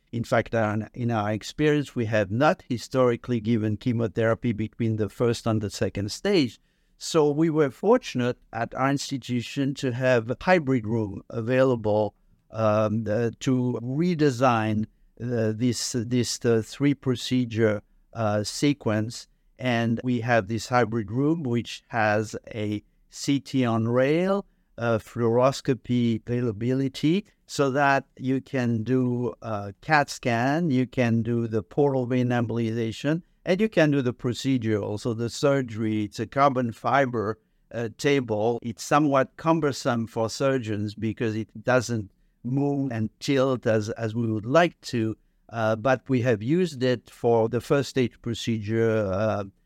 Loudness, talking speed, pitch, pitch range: -25 LUFS, 140 wpm, 120 Hz, 110-135 Hz